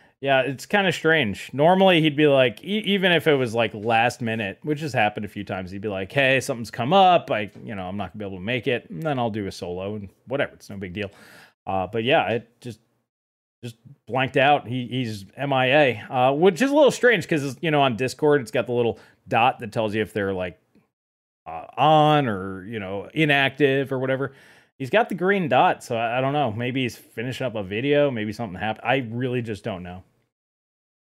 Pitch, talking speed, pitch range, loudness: 125 Hz, 230 wpm, 105-145 Hz, -22 LUFS